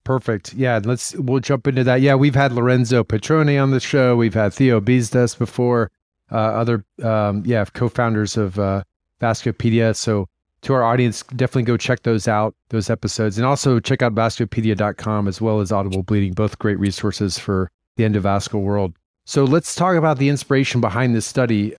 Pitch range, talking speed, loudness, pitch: 105-125 Hz, 180 wpm, -19 LUFS, 115 Hz